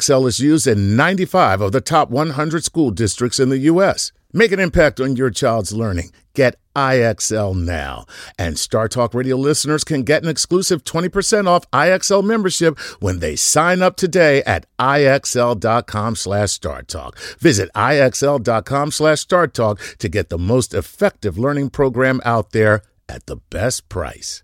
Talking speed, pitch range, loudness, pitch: 145 wpm, 110-155 Hz, -16 LUFS, 130 Hz